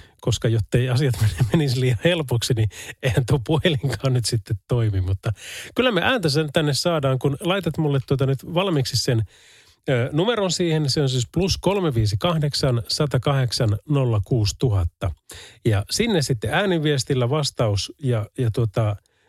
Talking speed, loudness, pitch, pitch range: 135 wpm, -22 LUFS, 130 Hz, 115-150 Hz